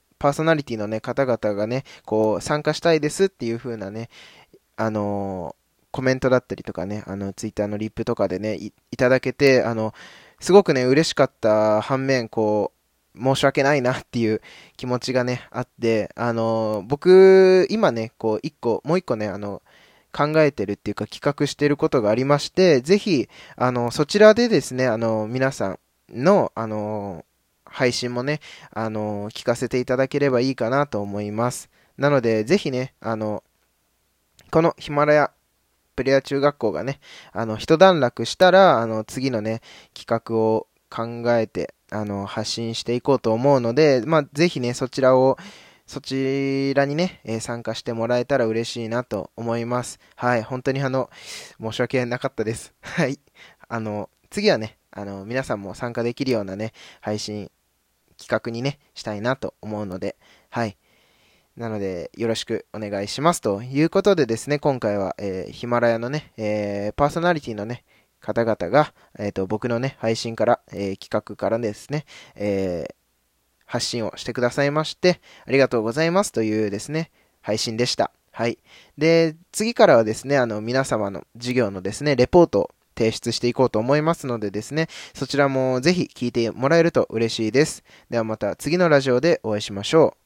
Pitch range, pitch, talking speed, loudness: 110-140 Hz, 120 Hz, 335 characters per minute, -22 LUFS